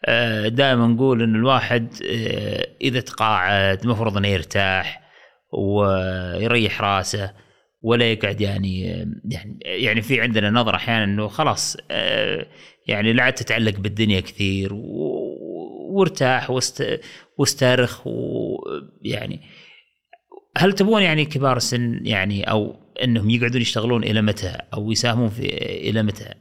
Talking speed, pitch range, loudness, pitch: 105 wpm, 105-130 Hz, -20 LUFS, 115 Hz